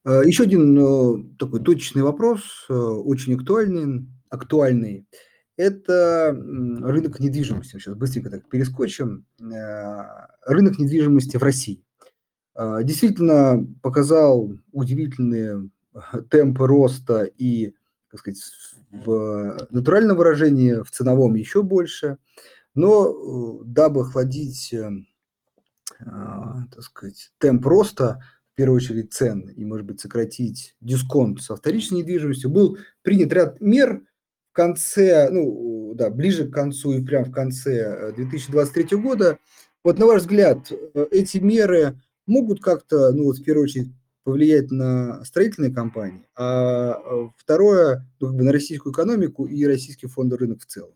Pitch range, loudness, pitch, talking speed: 120-155 Hz, -20 LUFS, 135 Hz, 120 wpm